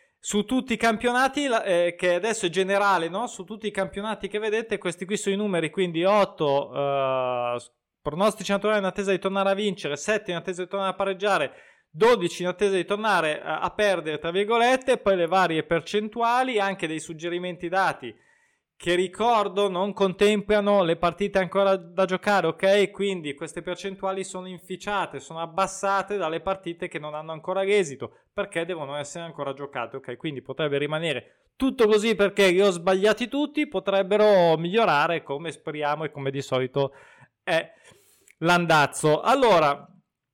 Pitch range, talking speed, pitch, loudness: 165-205 Hz, 160 wpm, 190 Hz, -24 LUFS